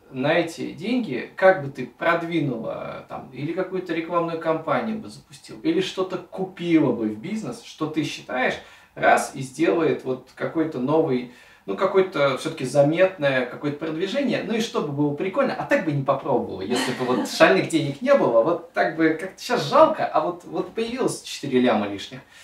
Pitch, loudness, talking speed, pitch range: 165 Hz, -23 LUFS, 175 wpm, 140-190 Hz